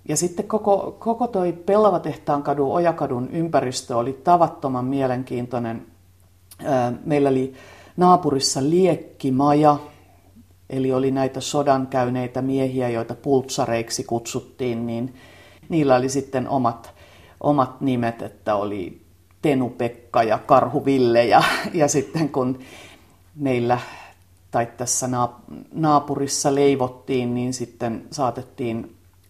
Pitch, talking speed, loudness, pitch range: 130 Hz, 100 wpm, -21 LUFS, 115-145 Hz